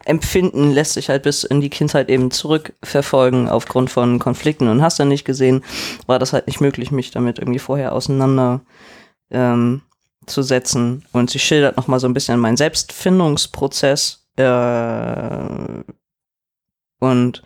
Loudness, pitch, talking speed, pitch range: -17 LUFS, 130 Hz, 140 wpm, 125-140 Hz